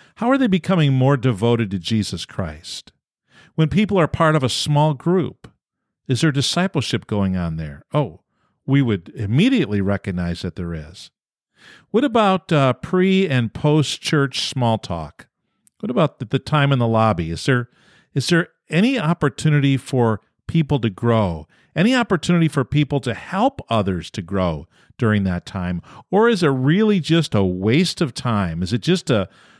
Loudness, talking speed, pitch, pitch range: -19 LUFS, 165 wpm, 130 Hz, 105-165 Hz